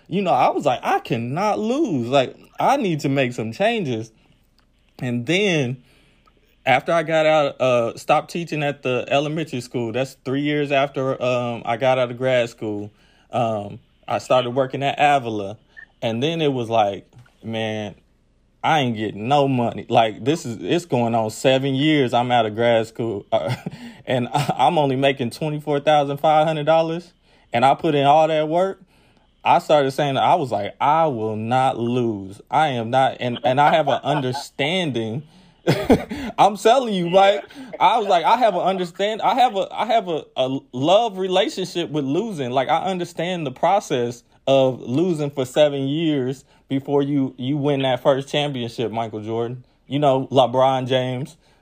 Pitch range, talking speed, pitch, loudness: 120-155 Hz, 175 wpm, 135 Hz, -20 LUFS